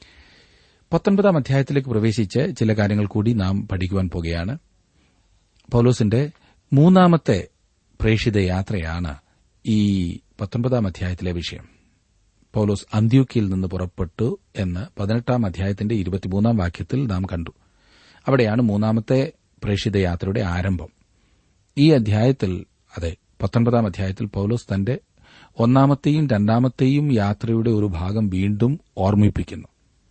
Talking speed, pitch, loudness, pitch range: 80 wpm, 105 Hz, -21 LUFS, 95-120 Hz